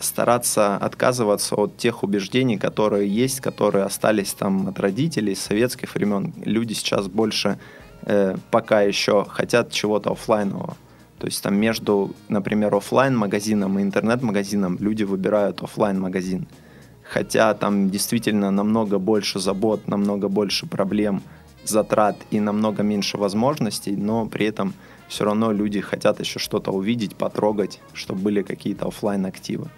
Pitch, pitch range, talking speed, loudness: 105 Hz, 100-110 Hz, 135 wpm, -22 LUFS